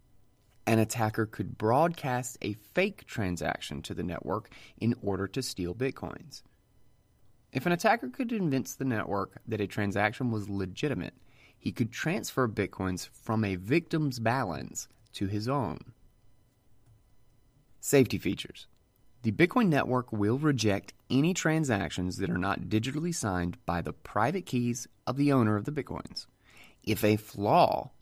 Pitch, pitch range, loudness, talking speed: 115 Hz, 105-135 Hz, -30 LUFS, 140 wpm